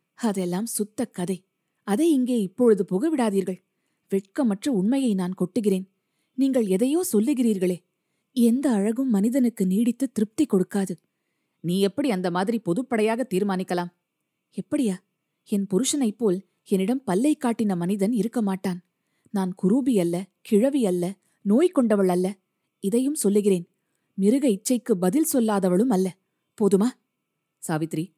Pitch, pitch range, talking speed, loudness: 200 Hz, 185-240 Hz, 115 wpm, -24 LUFS